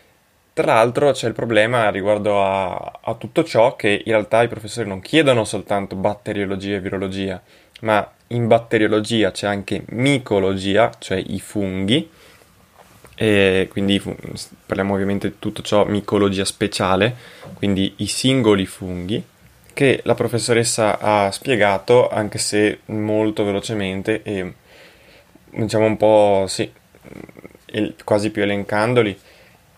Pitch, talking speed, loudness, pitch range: 105 Hz, 120 wpm, -19 LUFS, 100-110 Hz